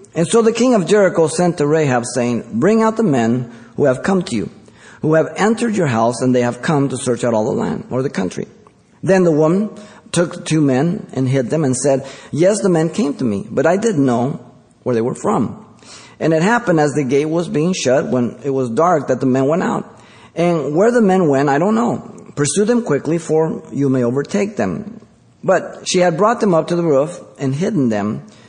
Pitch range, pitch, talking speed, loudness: 130-190 Hz, 155 Hz, 225 wpm, -16 LUFS